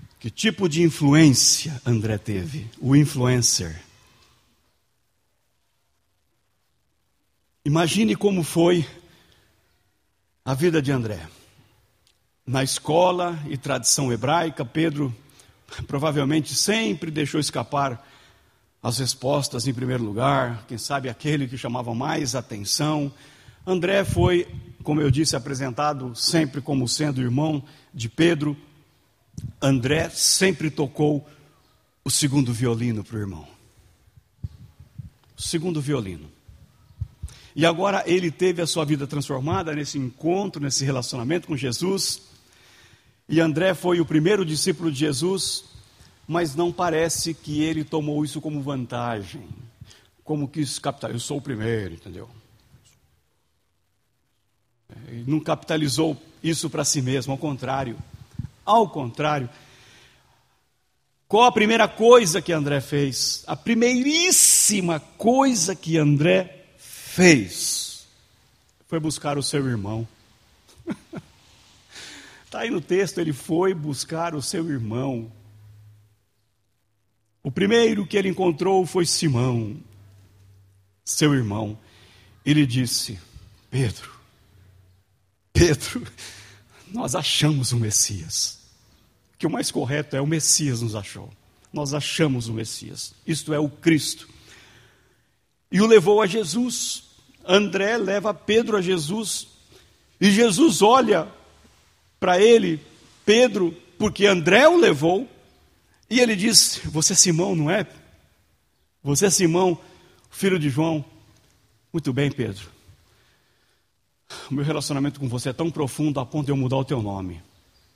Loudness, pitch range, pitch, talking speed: -21 LUFS, 115-165 Hz, 140 Hz, 115 wpm